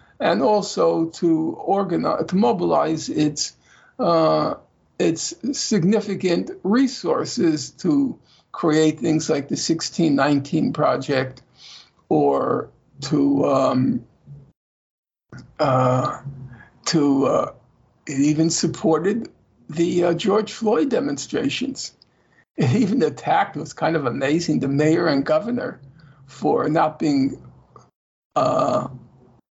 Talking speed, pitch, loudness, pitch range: 95 wpm, 160 Hz, -21 LUFS, 140-195 Hz